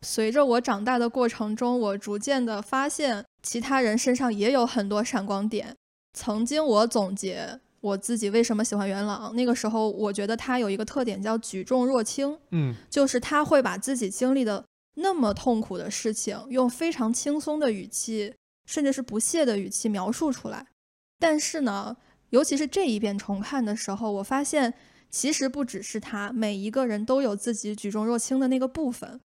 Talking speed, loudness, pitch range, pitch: 285 characters per minute, -26 LUFS, 210-265 Hz, 235 Hz